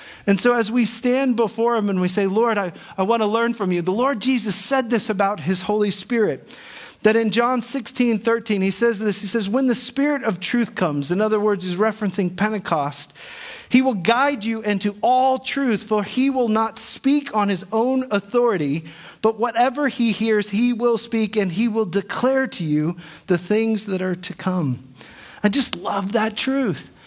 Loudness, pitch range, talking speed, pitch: -21 LUFS, 200-245 Hz, 195 wpm, 220 Hz